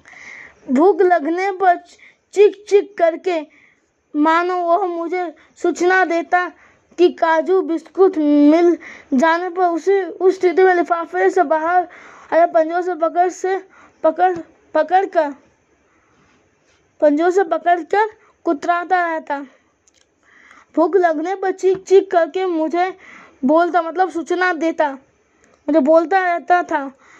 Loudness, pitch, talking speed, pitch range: -17 LUFS, 350 Hz, 115 wpm, 325-370 Hz